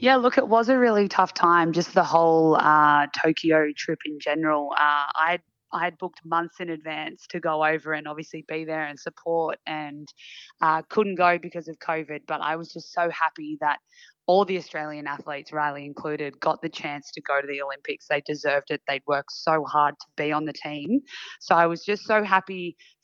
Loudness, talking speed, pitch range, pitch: -24 LUFS, 205 wpm, 150-170 Hz, 155 Hz